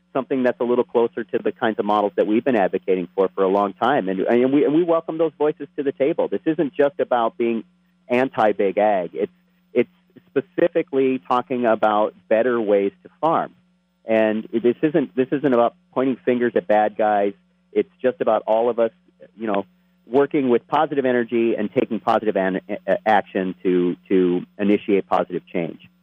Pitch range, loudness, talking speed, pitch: 105-145 Hz, -21 LUFS, 180 wpm, 120 Hz